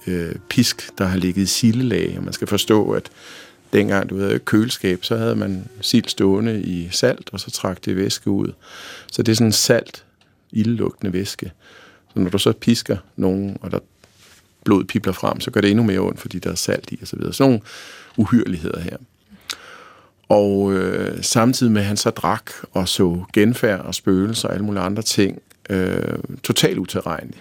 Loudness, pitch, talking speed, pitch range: -20 LUFS, 100 Hz, 190 wpm, 95-110 Hz